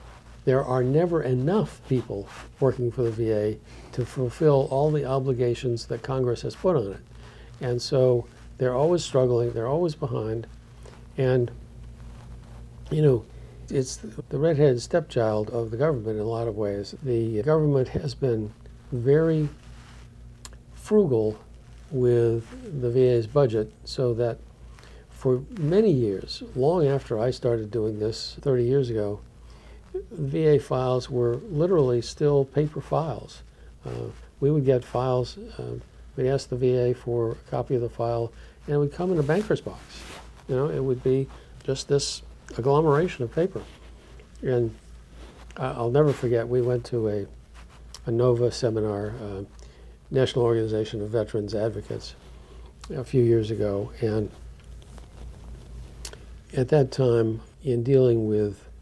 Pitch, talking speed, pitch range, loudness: 120 Hz, 140 wpm, 110-135 Hz, -25 LUFS